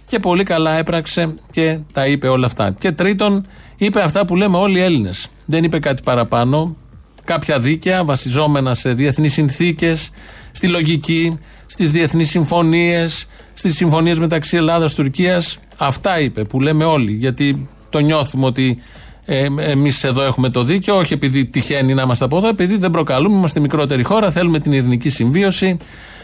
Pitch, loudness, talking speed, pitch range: 155 Hz, -15 LUFS, 160 wpm, 135-170 Hz